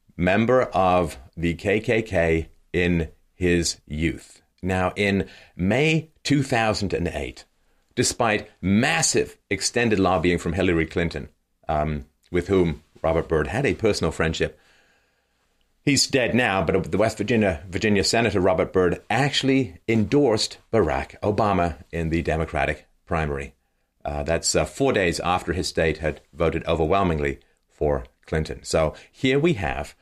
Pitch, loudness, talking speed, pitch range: 90 Hz, -23 LUFS, 125 wpm, 80-105 Hz